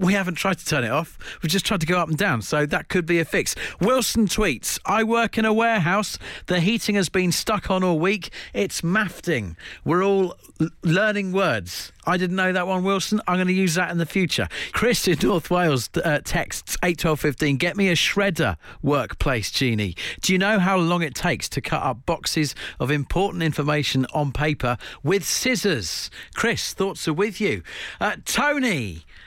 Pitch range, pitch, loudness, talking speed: 150-195 Hz, 175 Hz, -22 LUFS, 195 wpm